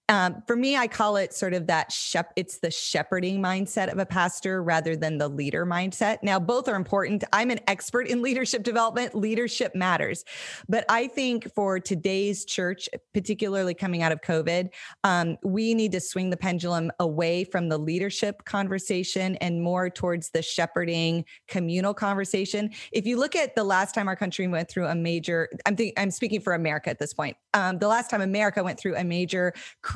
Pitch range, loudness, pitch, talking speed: 175-210 Hz, -26 LUFS, 190 Hz, 190 wpm